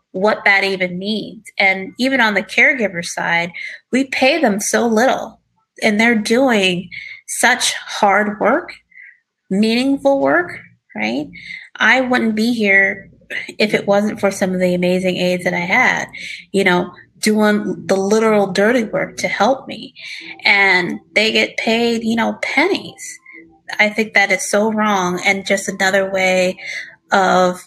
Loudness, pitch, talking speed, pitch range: -15 LUFS, 210 Hz, 145 wpm, 190-240 Hz